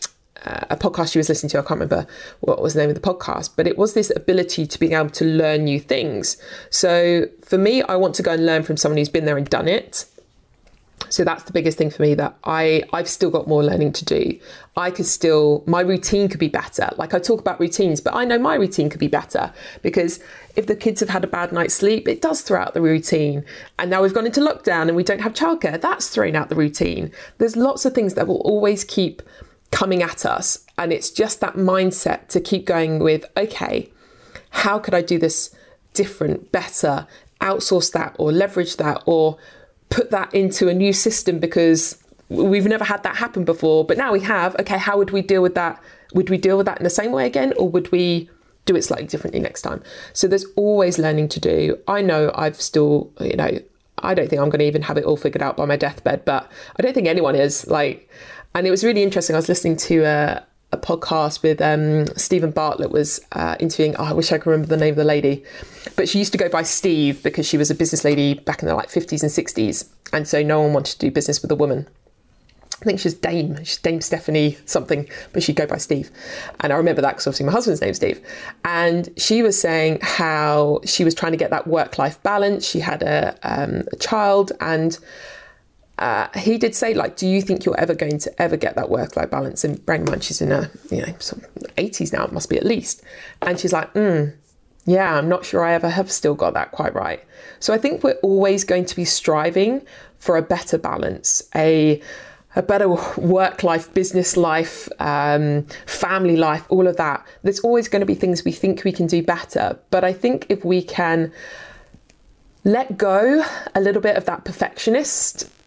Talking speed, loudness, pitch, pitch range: 225 wpm, -19 LUFS, 175 Hz, 155-195 Hz